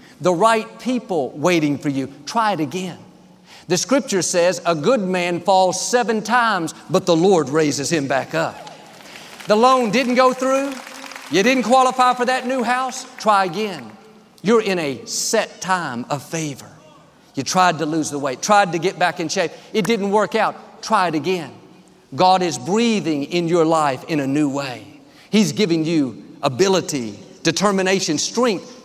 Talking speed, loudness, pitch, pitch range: 170 wpm, -19 LUFS, 185 Hz, 160-225 Hz